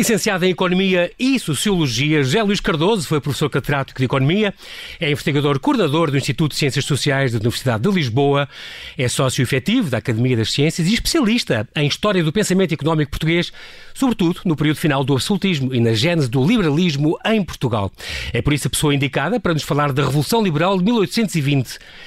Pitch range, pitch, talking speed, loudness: 140-185 Hz, 155 Hz, 180 wpm, -18 LUFS